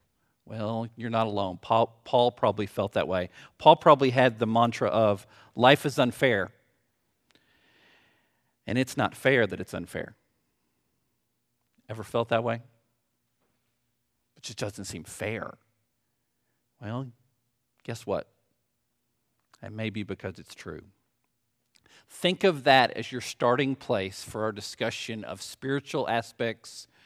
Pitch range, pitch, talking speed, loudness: 110-125 Hz, 115 Hz, 125 wpm, -27 LUFS